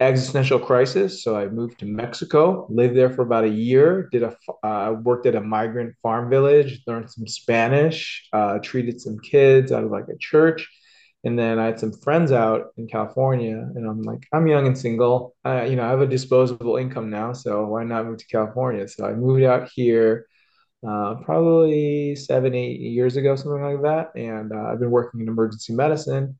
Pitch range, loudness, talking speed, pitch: 115-135 Hz, -21 LUFS, 200 wpm, 125 Hz